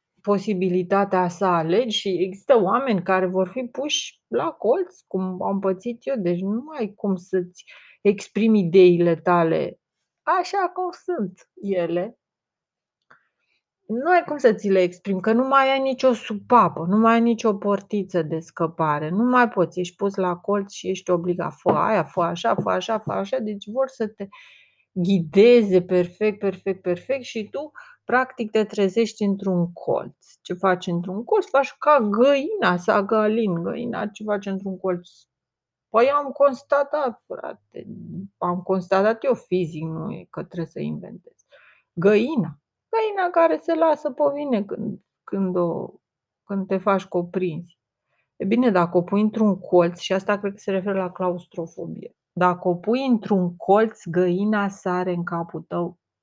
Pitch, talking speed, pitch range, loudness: 200 Hz, 155 wpm, 180-230 Hz, -22 LUFS